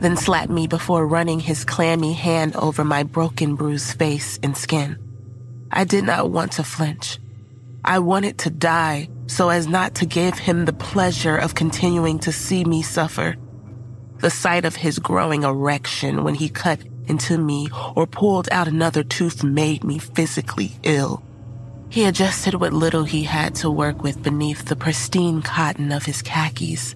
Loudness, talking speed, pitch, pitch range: -20 LUFS, 165 wpm, 155 Hz, 140-165 Hz